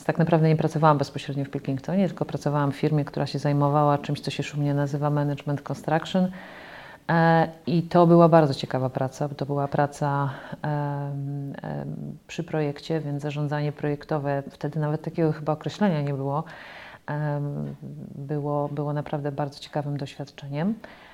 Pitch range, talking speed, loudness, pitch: 140-155 Hz, 140 wpm, -25 LUFS, 145 Hz